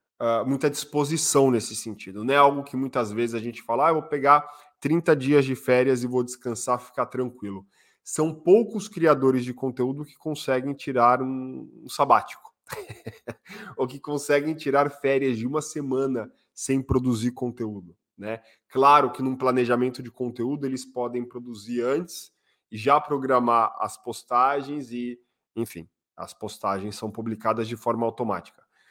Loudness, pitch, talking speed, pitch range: -24 LUFS, 130 Hz, 155 wpm, 120-140 Hz